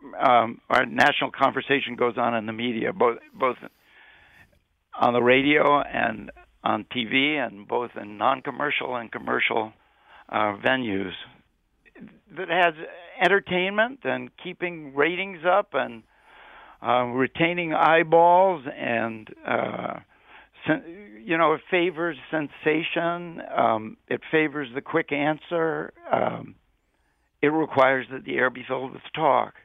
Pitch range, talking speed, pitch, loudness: 125-165 Hz, 120 wpm, 145 Hz, -24 LUFS